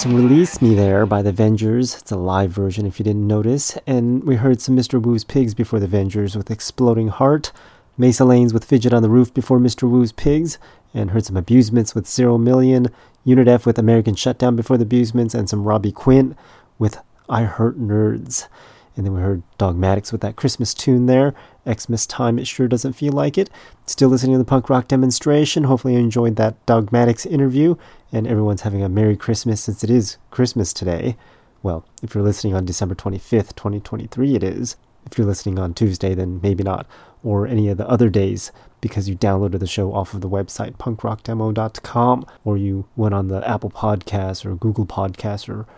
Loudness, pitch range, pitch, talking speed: -18 LUFS, 100-125 Hz, 115 Hz, 195 wpm